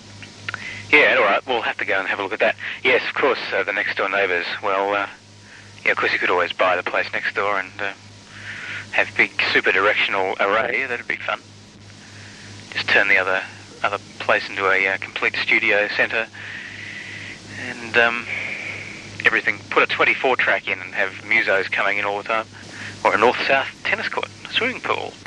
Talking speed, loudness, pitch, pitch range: 190 wpm, -19 LUFS, 105 Hz, 100-105 Hz